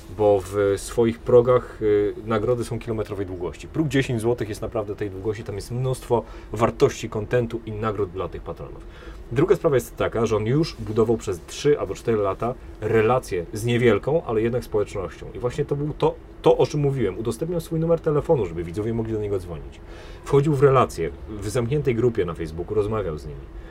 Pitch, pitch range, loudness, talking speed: 115 Hz, 105-130 Hz, -23 LUFS, 185 wpm